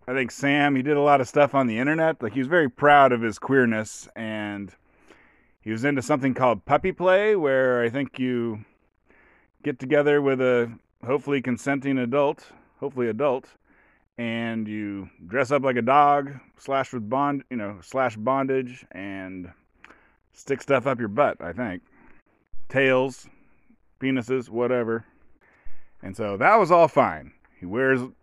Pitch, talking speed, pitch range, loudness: 130 Hz, 155 wpm, 115-140 Hz, -23 LUFS